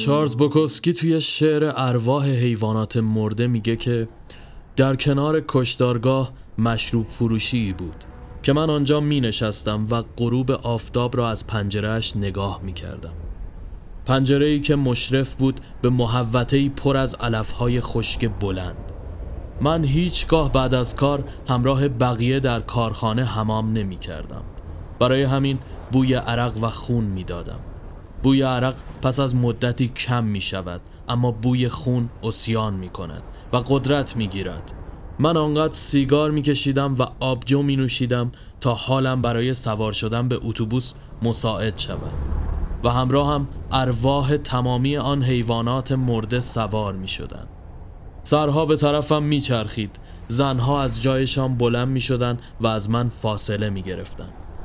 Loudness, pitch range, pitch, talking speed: -21 LUFS, 105-135 Hz, 120 Hz, 140 wpm